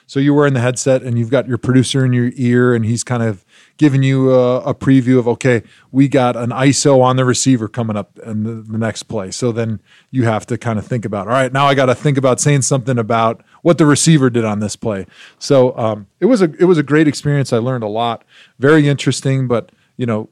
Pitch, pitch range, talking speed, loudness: 125 Hz, 115-140 Hz, 250 wpm, -15 LUFS